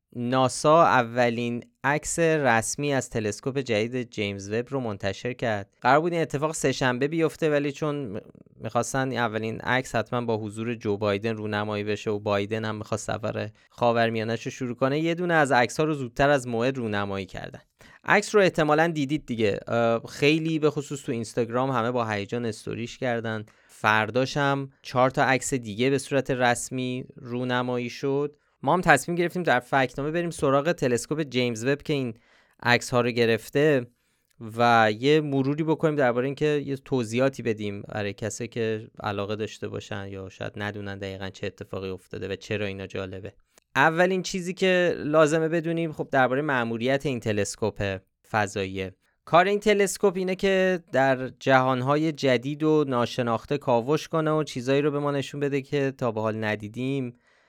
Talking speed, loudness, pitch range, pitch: 160 wpm, -25 LUFS, 110-145 Hz, 125 Hz